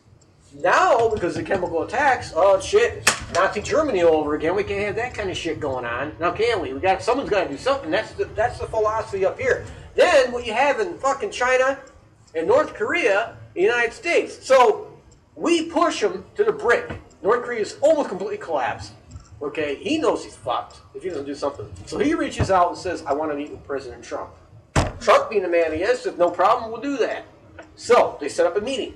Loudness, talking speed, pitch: -21 LUFS, 220 wpm, 255 Hz